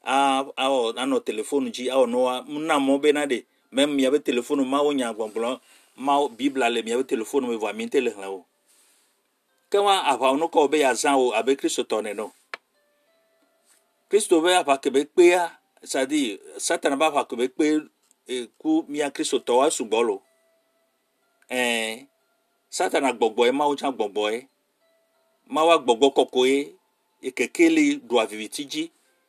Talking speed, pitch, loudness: 150 wpm, 160 Hz, -23 LUFS